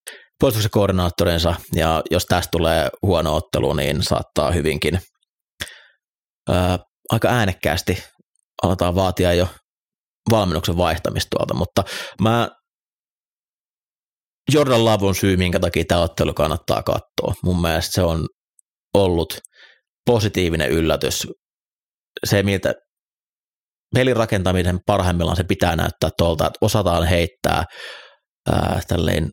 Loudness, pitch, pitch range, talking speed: -20 LUFS, 90 Hz, 85-105 Hz, 100 wpm